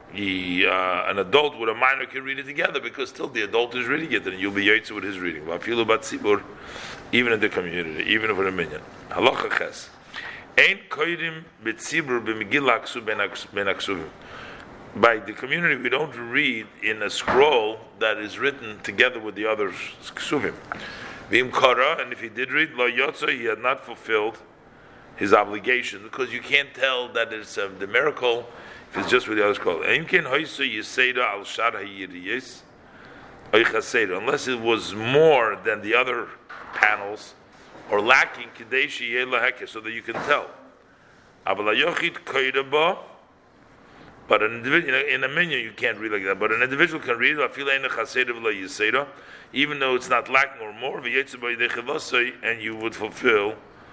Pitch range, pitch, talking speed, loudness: 110-135 Hz, 120 Hz, 135 wpm, -23 LUFS